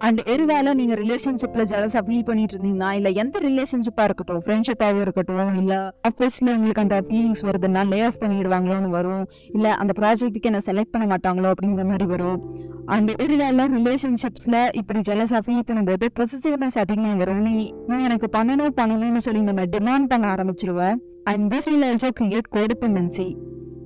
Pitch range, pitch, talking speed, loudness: 195-240 Hz, 215 Hz, 145 wpm, -21 LUFS